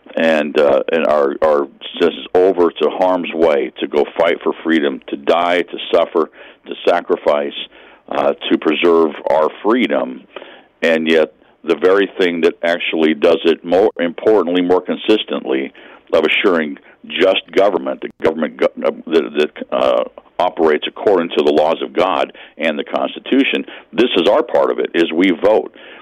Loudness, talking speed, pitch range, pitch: -16 LUFS, 150 wpm, 80-95 Hz, 85 Hz